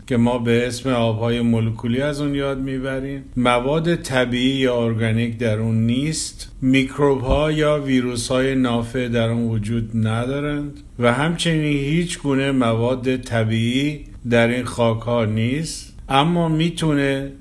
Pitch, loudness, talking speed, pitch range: 130 Hz, -20 LUFS, 140 wpm, 115-140 Hz